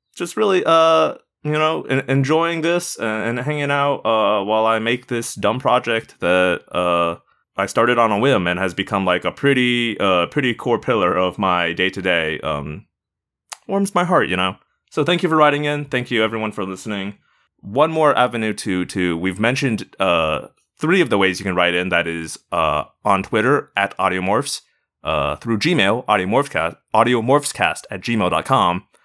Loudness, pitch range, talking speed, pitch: -18 LUFS, 95-140 Hz, 180 wpm, 110 Hz